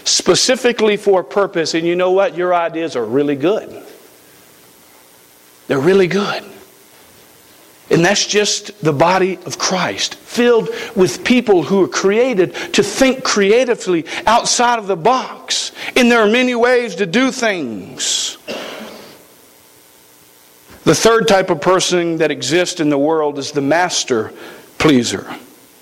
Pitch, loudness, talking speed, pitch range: 185 Hz, -15 LUFS, 135 wpm, 145-225 Hz